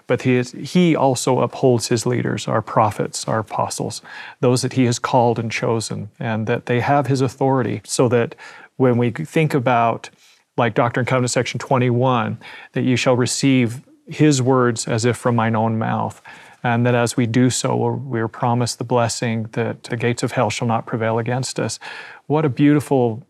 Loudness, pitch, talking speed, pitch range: -19 LUFS, 125 Hz, 185 wpm, 120-130 Hz